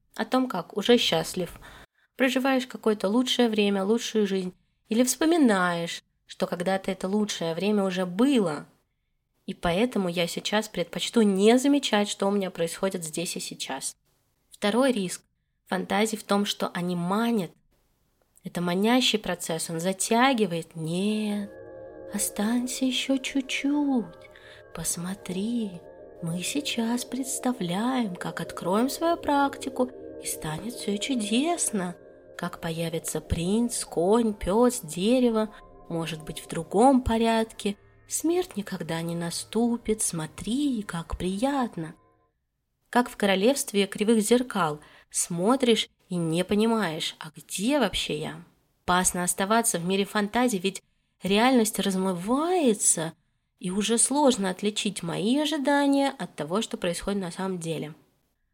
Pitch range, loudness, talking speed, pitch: 175-240 Hz, -26 LUFS, 120 wpm, 205 Hz